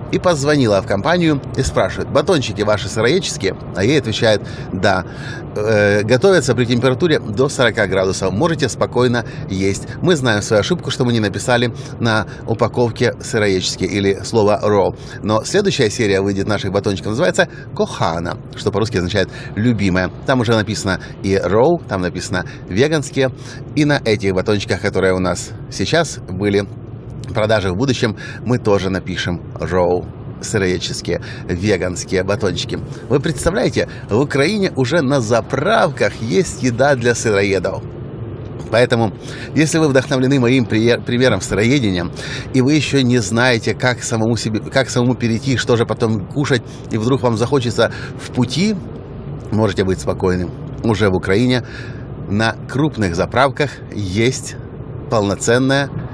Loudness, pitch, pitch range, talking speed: -17 LUFS, 120 Hz, 105-135 Hz, 135 wpm